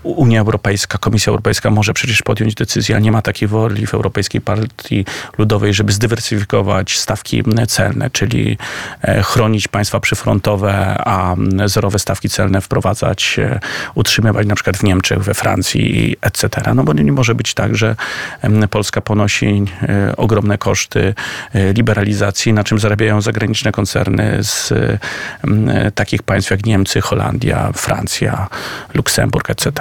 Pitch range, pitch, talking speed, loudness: 100-115 Hz, 105 Hz, 130 wpm, -15 LUFS